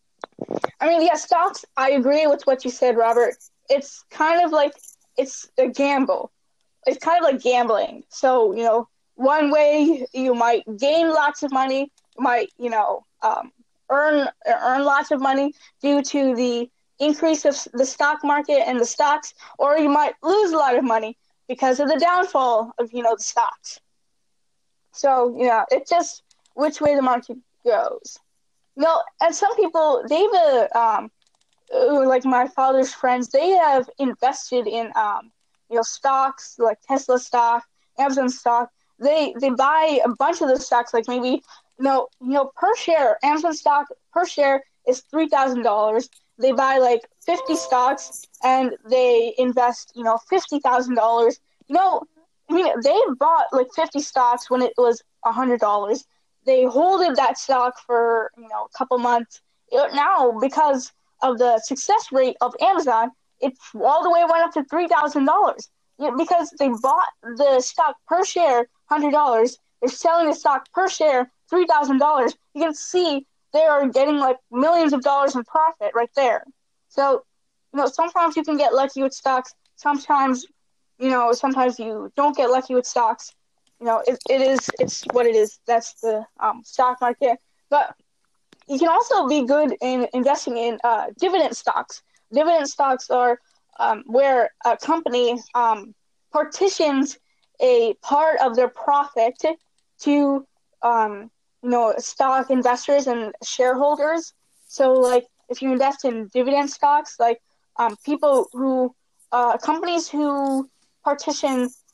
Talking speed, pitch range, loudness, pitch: 165 wpm, 245-310 Hz, -20 LUFS, 275 Hz